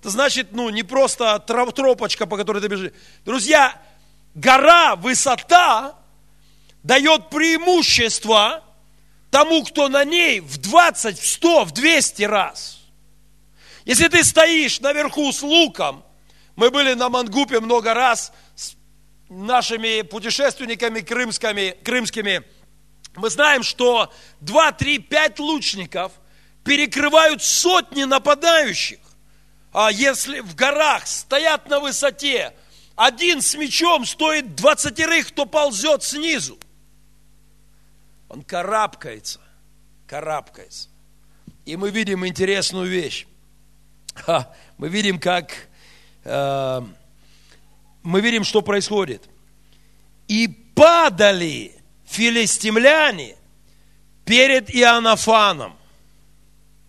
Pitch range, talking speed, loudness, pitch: 210-295 Hz, 90 wpm, -17 LUFS, 245 Hz